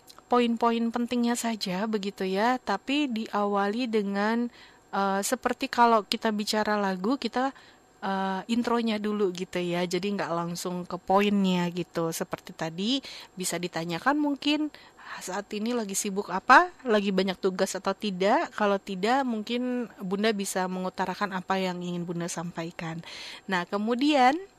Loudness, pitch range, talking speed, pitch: -27 LUFS, 185-235 Hz, 130 wpm, 205 Hz